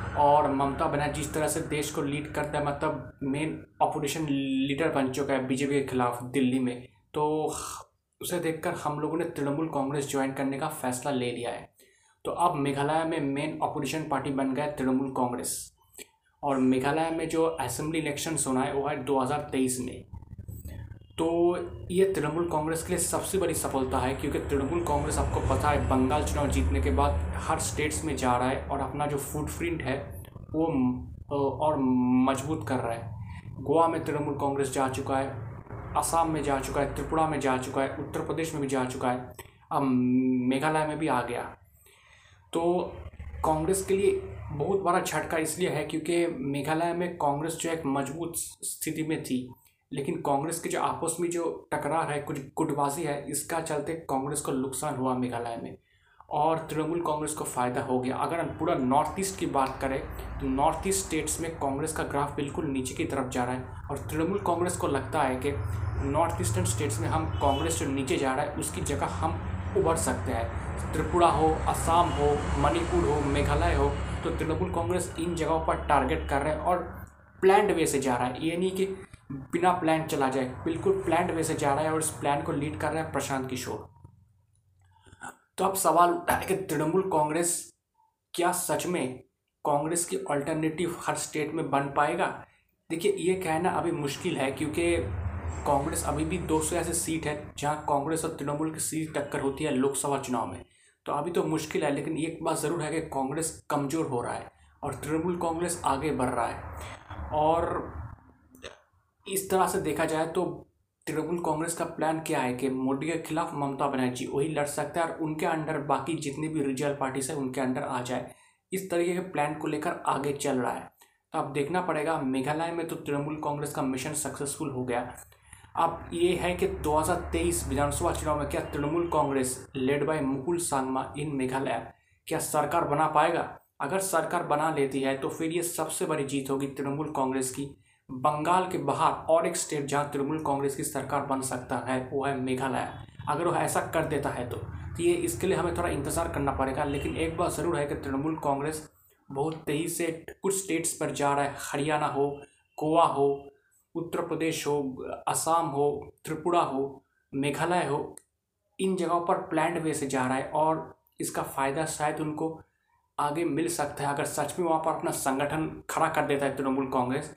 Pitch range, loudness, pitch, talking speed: 135-160 Hz, -29 LUFS, 145 Hz, 190 wpm